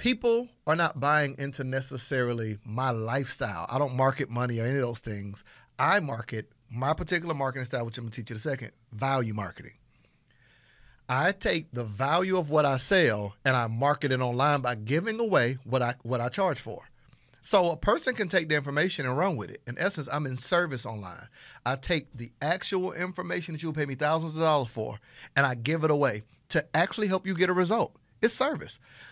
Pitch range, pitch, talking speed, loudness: 120-165 Hz, 135 Hz, 205 wpm, -28 LUFS